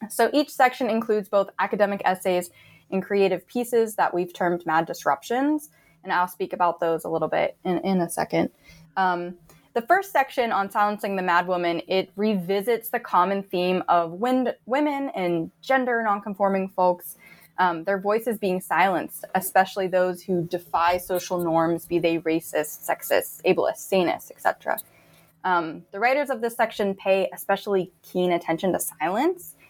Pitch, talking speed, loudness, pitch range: 190 Hz, 160 wpm, -24 LUFS, 175-220 Hz